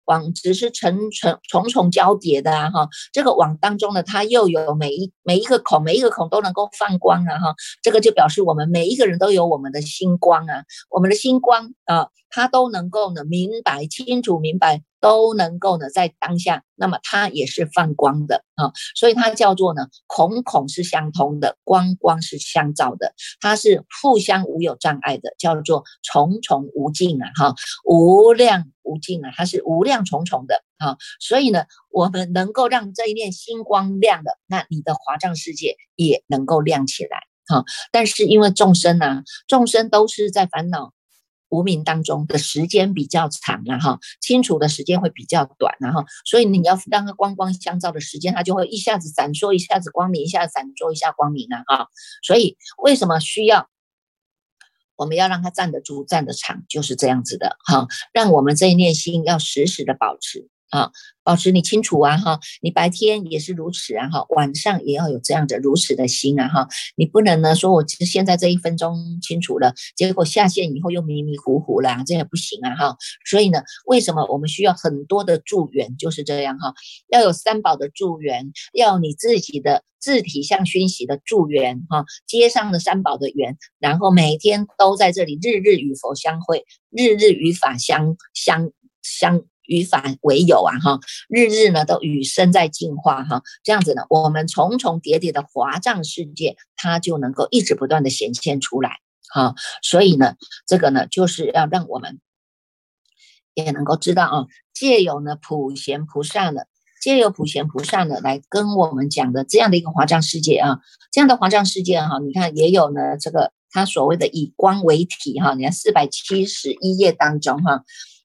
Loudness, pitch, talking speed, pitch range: -18 LUFS, 175 Hz, 280 characters per minute, 155-210 Hz